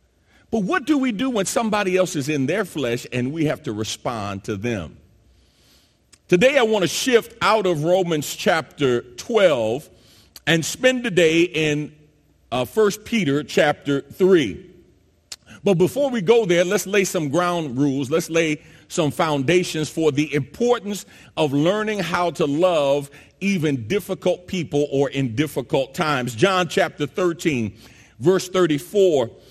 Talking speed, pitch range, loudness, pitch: 150 wpm, 145-190 Hz, -21 LUFS, 165 Hz